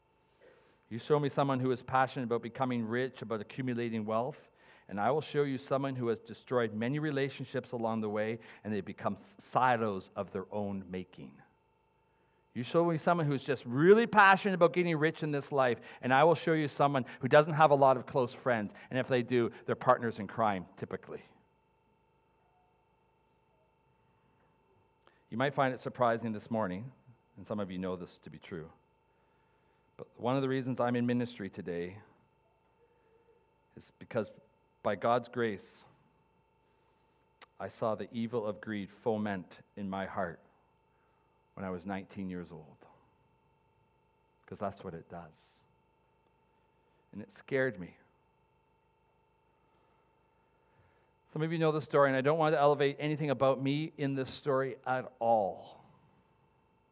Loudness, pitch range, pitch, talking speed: -32 LUFS, 110-150 Hz, 130 Hz, 155 wpm